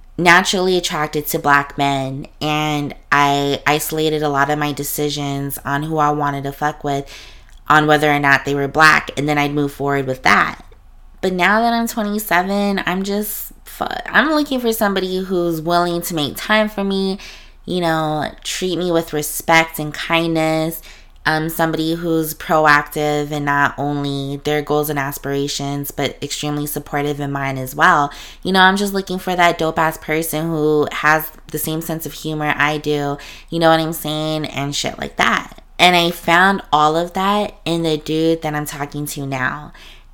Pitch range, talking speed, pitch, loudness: 145-170 Hz, 180 wpm, 155 Hz, -17 LUFS